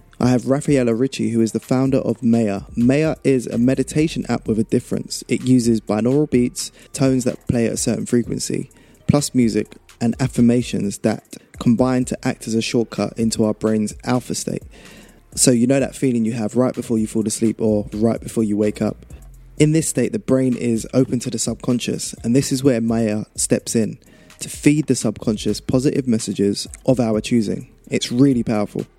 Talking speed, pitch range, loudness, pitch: 190 wpm, 110-130 Hz, -19 LUFS, 120 Hz